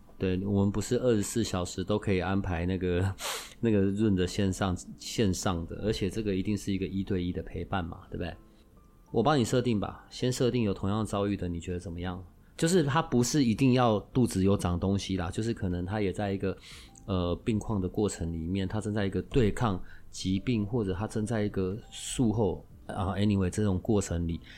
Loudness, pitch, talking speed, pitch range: -30 LUFS, 100 Hz, 310 characters per minute, 95-110 Hz